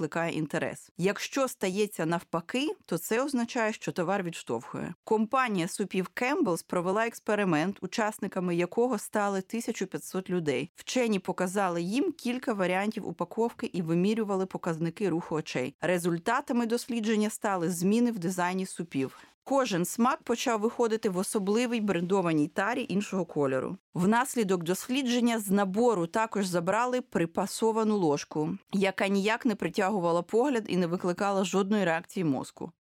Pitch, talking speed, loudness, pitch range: 195 Hz, 125 wpm, -29 LUFS, 180-230 Hz